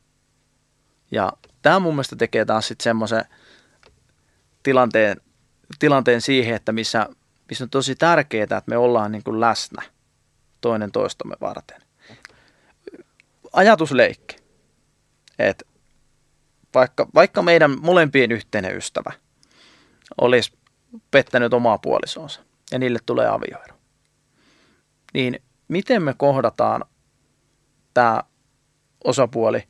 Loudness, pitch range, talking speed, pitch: -19 LUFS, 115-140 Hz, 95 wpm, 125 Hz